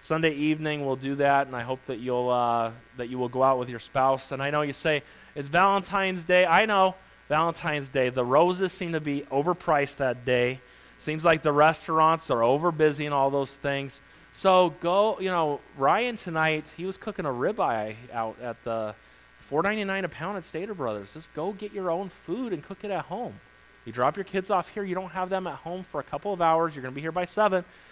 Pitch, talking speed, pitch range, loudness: 155 Hz, 225 wpm, 130-180 Hz, -26 LUFS